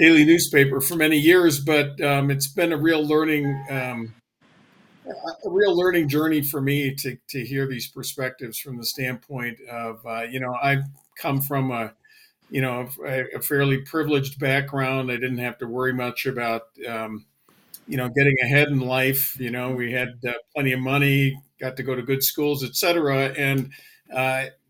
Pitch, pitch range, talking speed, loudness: 135 Hz, 125-145 Hz, 175 wpm, -22 LUFS